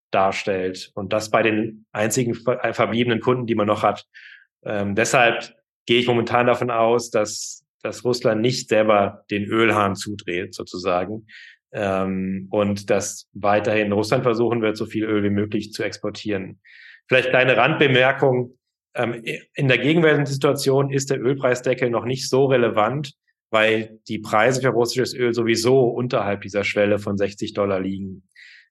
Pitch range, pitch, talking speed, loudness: 105-125 Hz, 110 Hz, 150 wpm, -20 LUFS